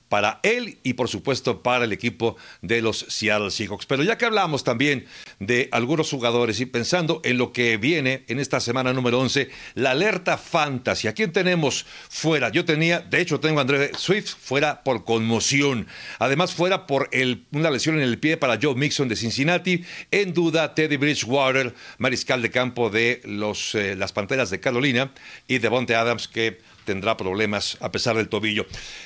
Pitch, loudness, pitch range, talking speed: 130 Hz, -22 LUFS, 115-150 Hz, 180 wpm